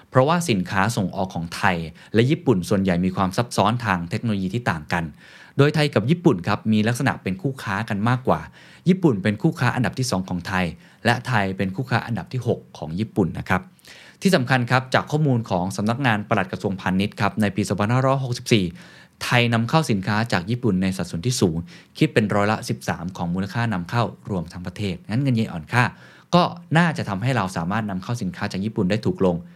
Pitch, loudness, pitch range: 110 Hz, -22 LUFS, 95-125 Hz